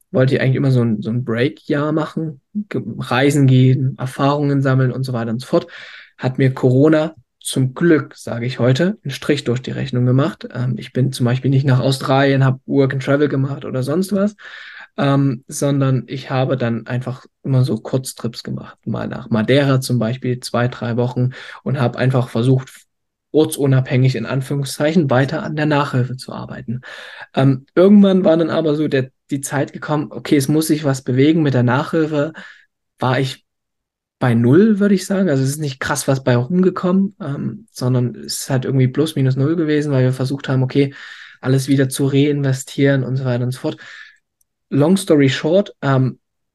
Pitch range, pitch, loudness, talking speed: 125-150 Hz, 135 Hz, -17 LUFS, 185 wpm